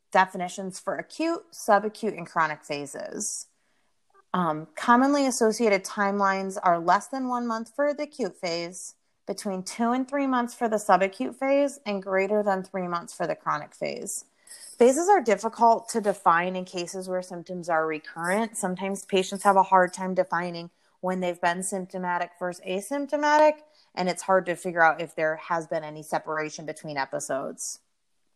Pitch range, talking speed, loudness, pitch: 175-230 Hz, 160 wpm, -26 LUFS, 190 Hz